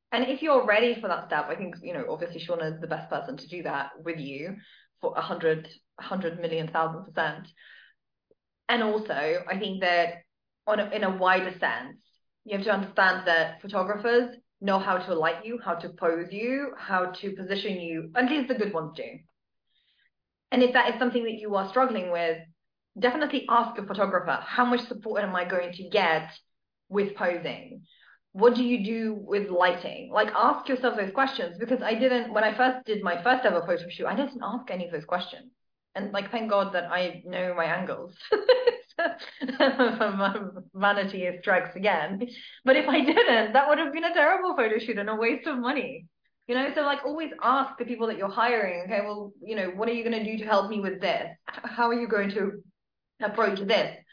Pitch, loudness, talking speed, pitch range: 210 Hz, -27 LUFS, 200 wpm, 180-245 Hz